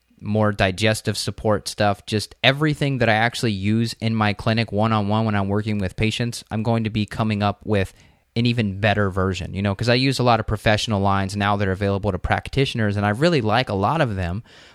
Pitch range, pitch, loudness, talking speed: 100-115 Hz, 105 Hz, -21 LUFS, 230 wpm